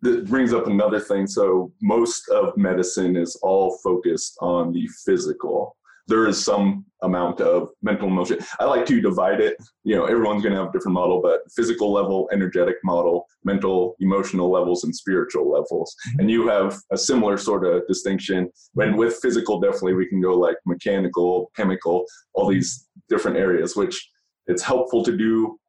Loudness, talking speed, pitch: -21 LUFS, 175 wpm, 115 Hz